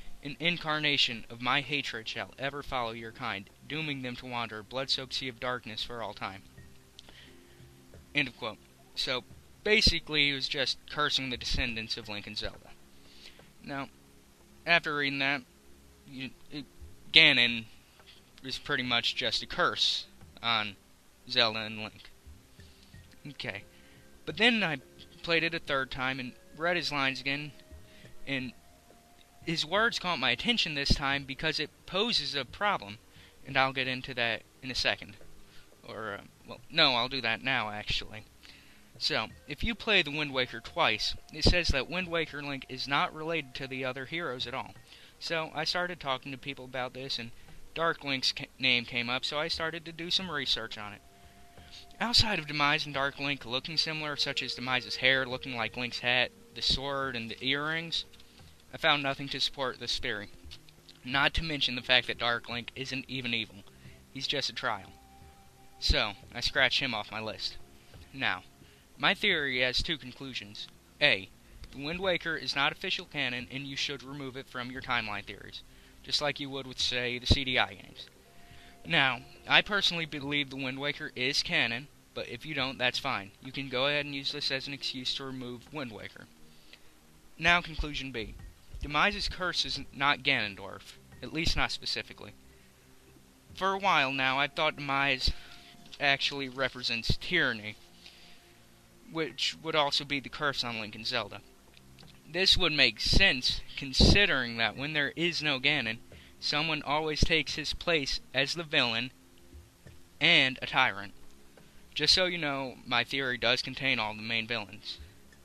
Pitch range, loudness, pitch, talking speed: 105-145 Hz, -29 LUFS, 130 Hz, 165 wpm